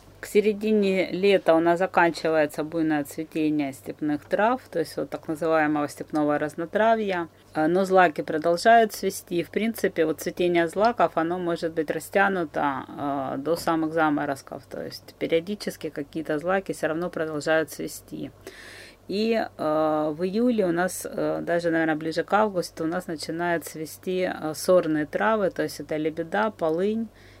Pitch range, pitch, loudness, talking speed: 155-185 Hz, 165 Hz, -25 LUFS, 140 wpm